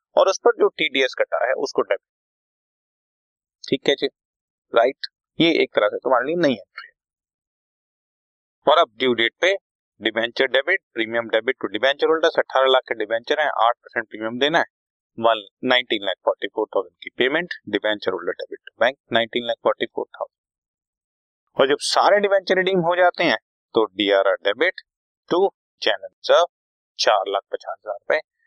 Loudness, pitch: -21 LUFS, 135 Hz